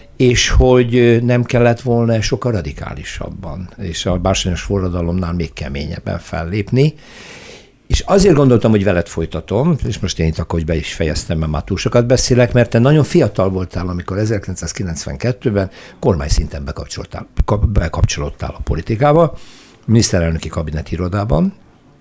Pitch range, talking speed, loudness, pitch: 85-120 Hz, 135 wpm, -16 LUFS, 100 Hz